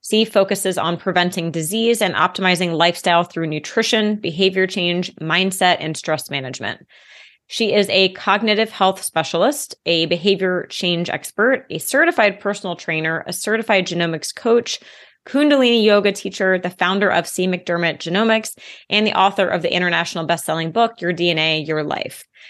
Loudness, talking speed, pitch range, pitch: -18 LUFS, 145 wpm, 170-205 Hz, 185 Hz